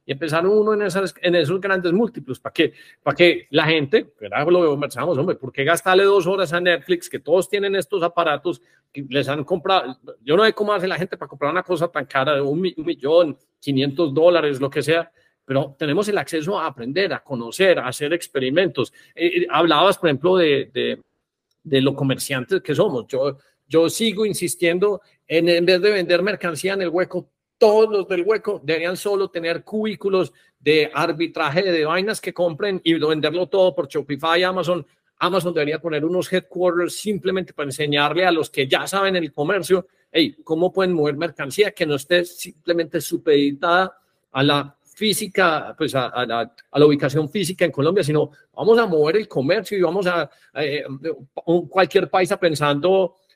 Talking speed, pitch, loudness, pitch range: 180 wpm, 175 Hz, -20 LUFS, 150-190 Hz